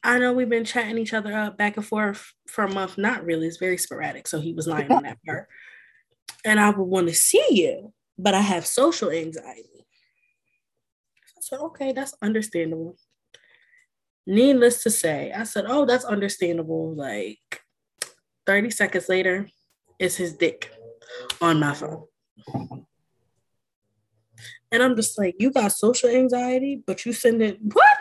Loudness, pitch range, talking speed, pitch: -22 LUFS, 170-255 Hz, 160 wpm, 210 Hz